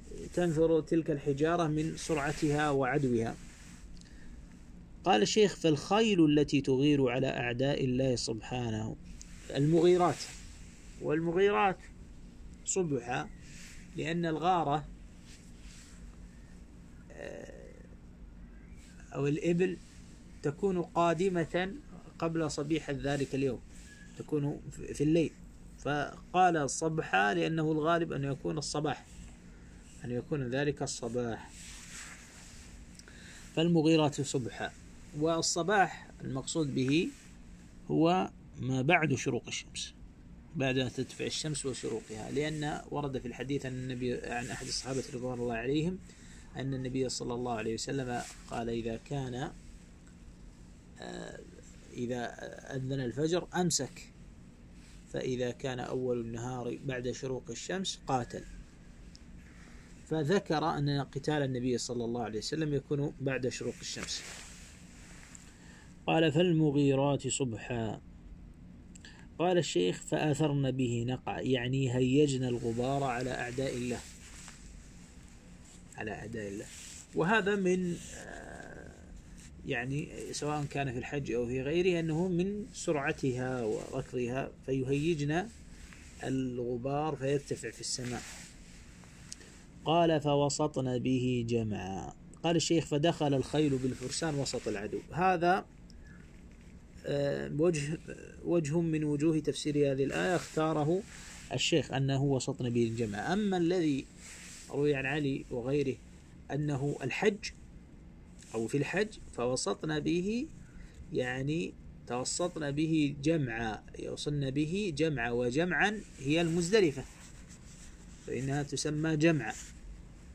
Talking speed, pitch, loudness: 95 wpm, 130 Hz, -32 LUFS